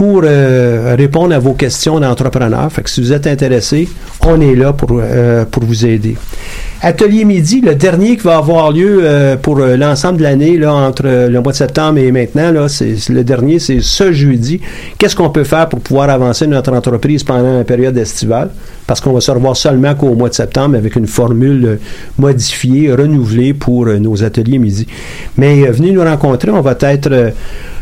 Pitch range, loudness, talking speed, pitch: 120-150 Hz, -10 LUFS, 195 wpm, 135 Hz